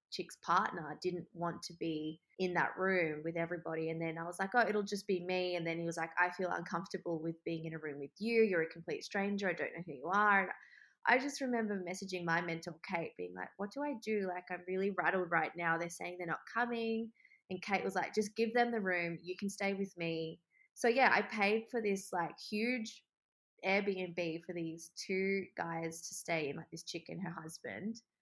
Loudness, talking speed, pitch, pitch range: -37 LUFS, 230 wpm, 180 Hz, 165-200 Hz